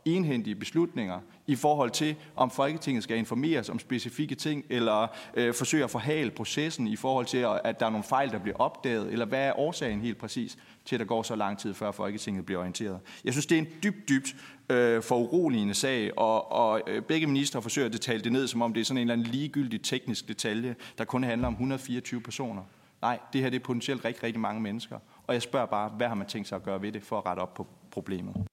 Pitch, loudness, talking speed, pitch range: 120 Hz, -30 LUFS, 235 wpm, 110-135 Hz